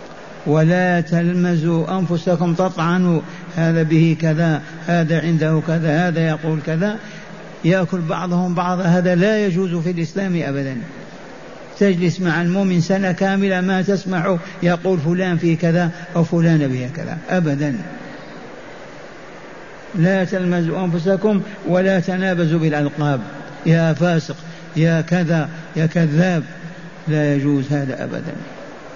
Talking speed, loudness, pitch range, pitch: 110 wpm, -18 LUFS, 160-185 Hz, 170 Hz